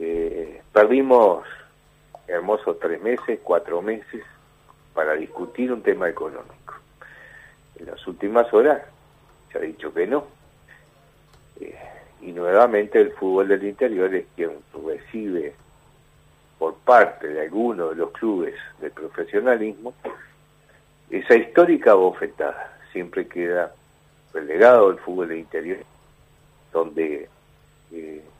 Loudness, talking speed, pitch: -21 LUFS, 110 wpm, 385 Hz